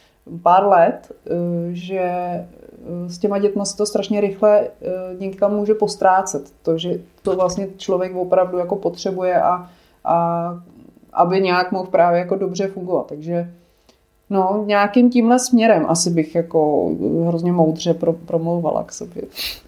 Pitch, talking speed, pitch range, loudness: 180 Hz, 130 wpm, 170-200 Hz, -18 LUFS